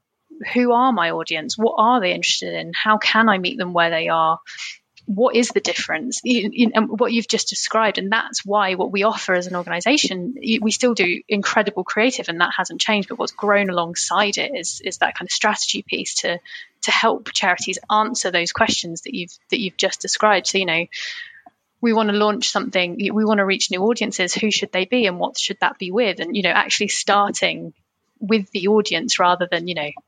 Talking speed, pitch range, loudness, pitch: 215 wpm, 180-225 Hz, -19 LUFS, 205 Hz